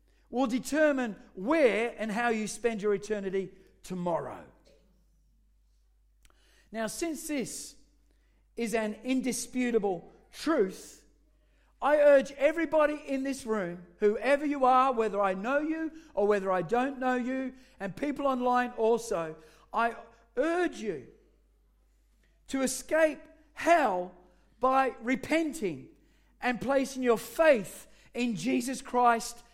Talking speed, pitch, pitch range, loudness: 110 wpm, 245 Hz, 215-275 Hz, -29 LUFS